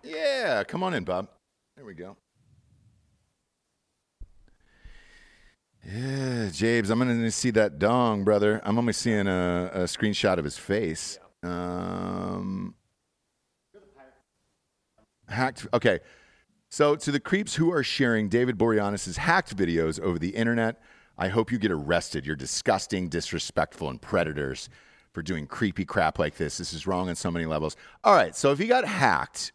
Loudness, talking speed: -26 LUFS, 150 wpm